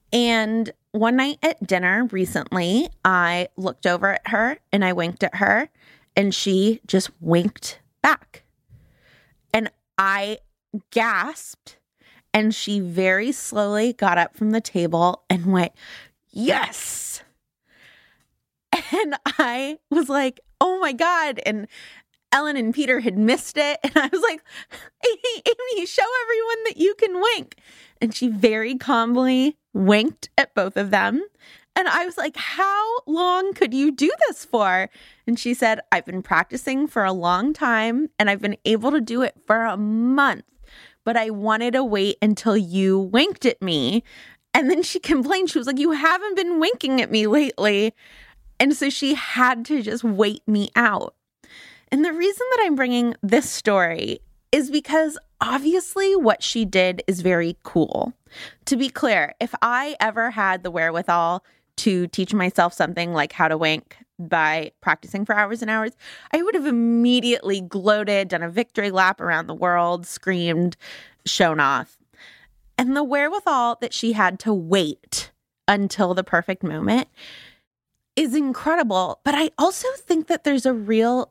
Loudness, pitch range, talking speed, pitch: -21 LUFS, 195-295 Hz, 155 wpm, 230 Hz